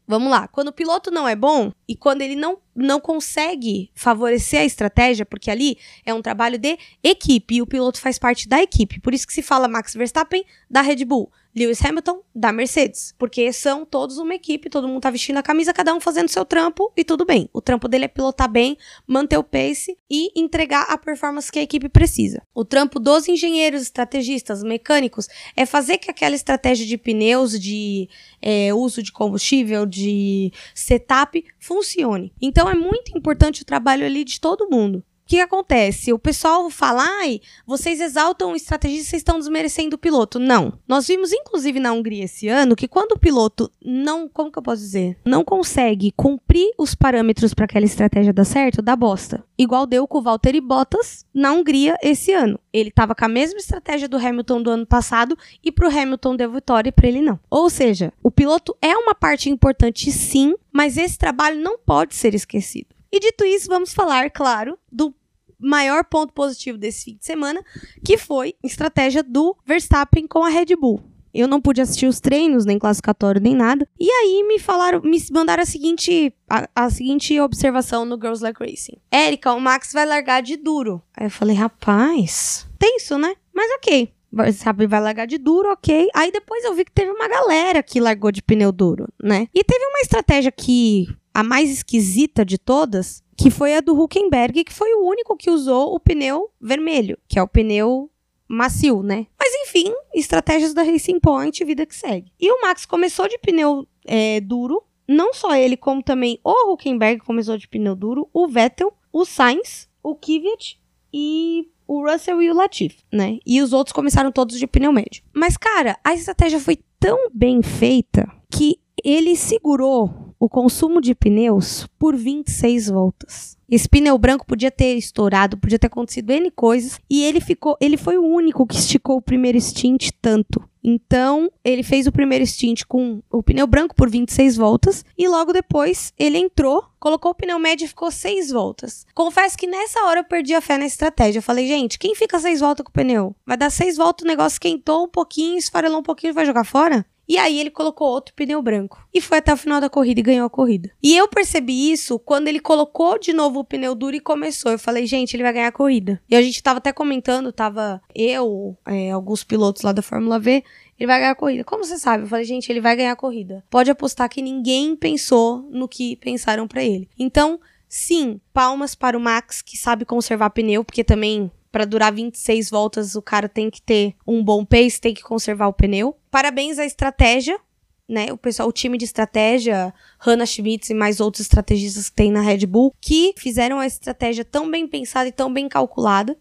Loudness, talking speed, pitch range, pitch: -18 LUFS, 200 wpm, 235-320 Hz, 270 Hz